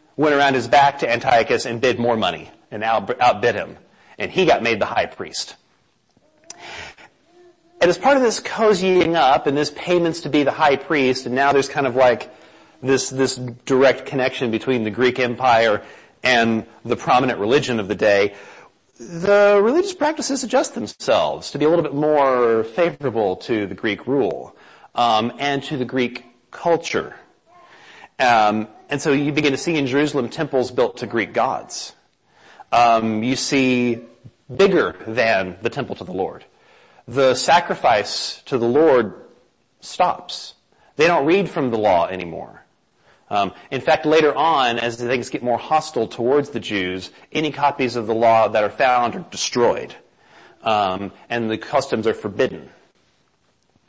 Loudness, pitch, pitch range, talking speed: -19 LUFS, 135 Hz, 120-160 Hz, 160 wpm